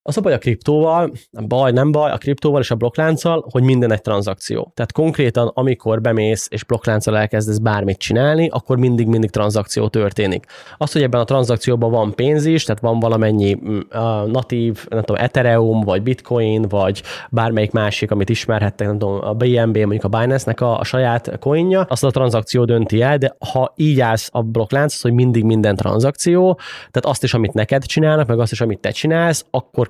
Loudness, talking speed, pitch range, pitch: -17 LUFS, 185 wpm, 110-135 Hz, 120 Hz